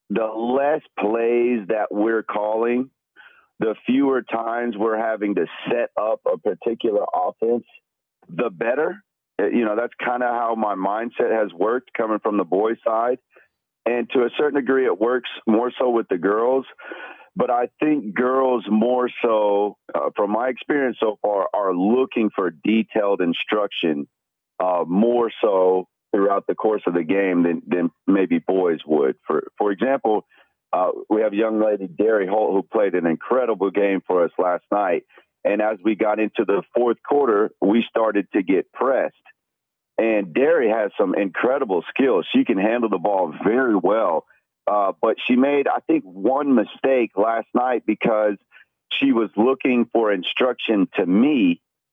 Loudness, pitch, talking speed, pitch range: -21 LUFS, 115 Hz, 160 wpm, 105-130 Hz